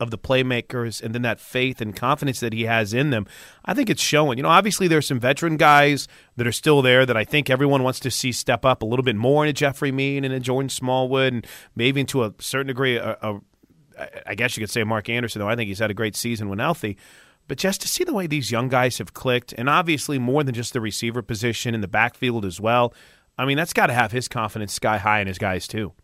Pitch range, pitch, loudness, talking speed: 115-135 Hz, 125 Hz, -21 LUFS, 260 wpm